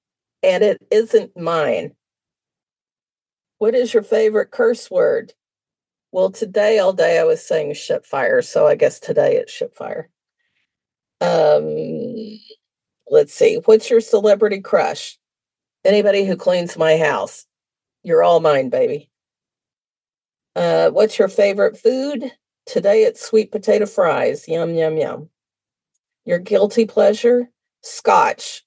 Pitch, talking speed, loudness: 355 Hz, 120 wpm, -17 LUFS